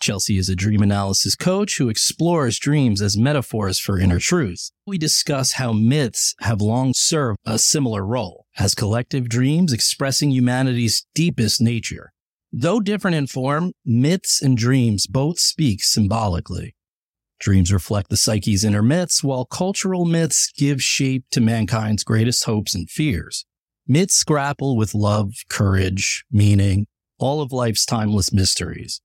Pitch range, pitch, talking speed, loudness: 105-145 Hz, 120 Hz, 145 wpm, -19 LUFS